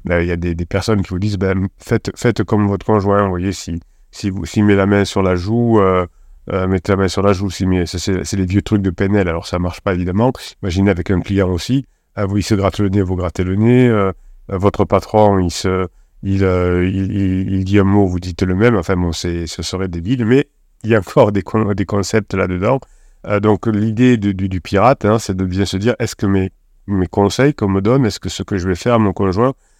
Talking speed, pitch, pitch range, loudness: 265 wpm, 100 Hz, 95-105 Hz, -16 LUFS